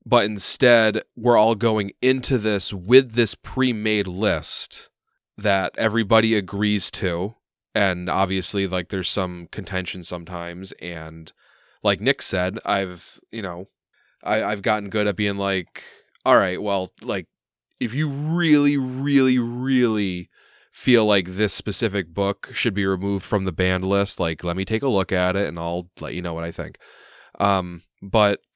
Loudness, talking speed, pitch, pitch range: -22 LUFS, 160 wpm, 100 Hz, 90-110 Hz